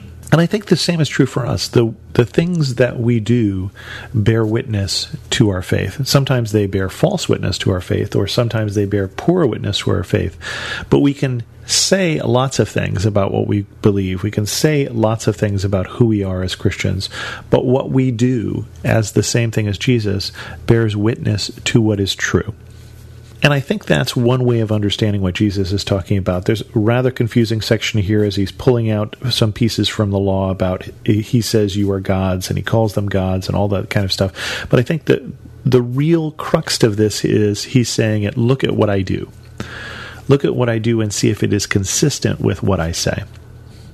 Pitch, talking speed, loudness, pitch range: 110 Hz, 210 wpm, -17 LUFS, 100-120 Hz